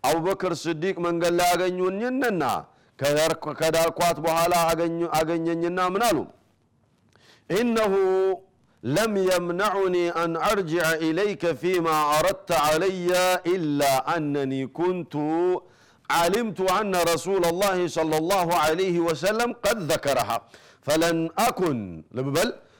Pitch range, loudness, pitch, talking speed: 160-190 Hz, -24 LUFS, 175 Hz, 90 wpm